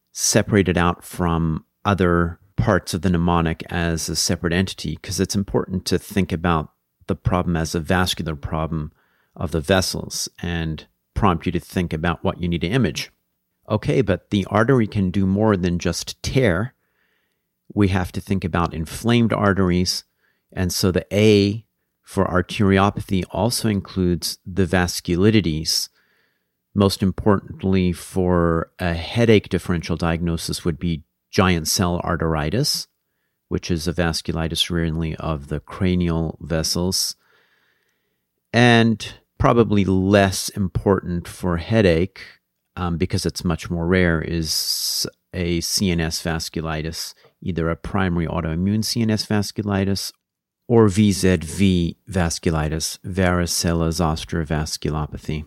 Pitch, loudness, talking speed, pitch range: 90 Hz, -21 LUFS, 125 wpm, 85-100 Hz